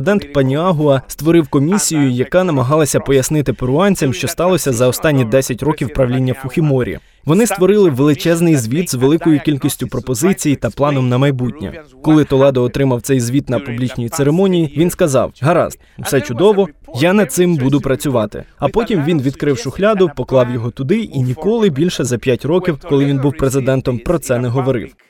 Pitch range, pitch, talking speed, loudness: 130-165 Hz, 140 Hz, 165 wpm, -15 LUFS